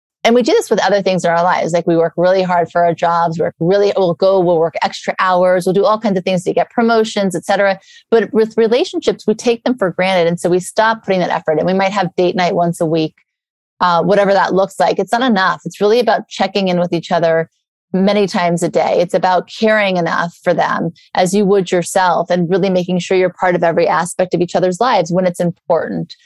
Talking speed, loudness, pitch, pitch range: 245 wpm, -14 LUFS, 185 Hz, 175-200 Hz